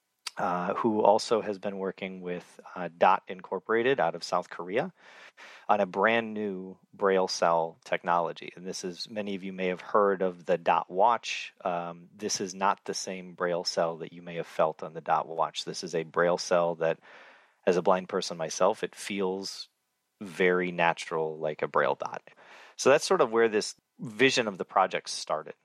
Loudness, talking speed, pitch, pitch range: -29 LUFS, 190 wpm, 95 Hz, 85-100 Hz